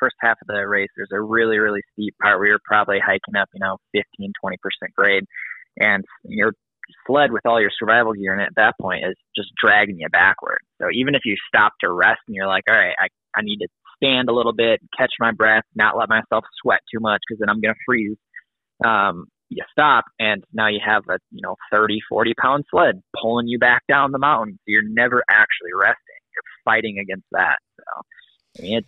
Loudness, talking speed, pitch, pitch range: -18 LUFS, 220 wpm, 110 Hz, 105-120 Hz